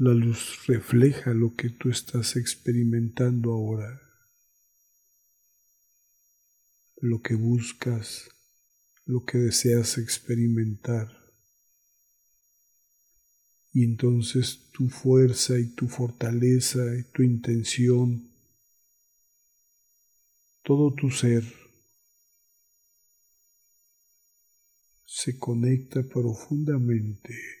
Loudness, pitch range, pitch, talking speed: -25 LUFS, 115-125 Hz, 120 Hz, 70 wpm